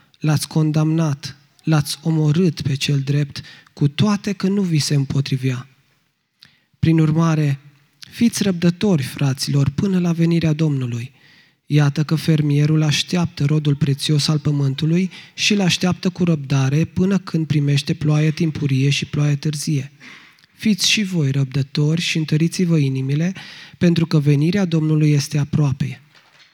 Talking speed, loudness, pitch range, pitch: 130 wpm, -19 LUFS, 145-165 Hz, 155 Hz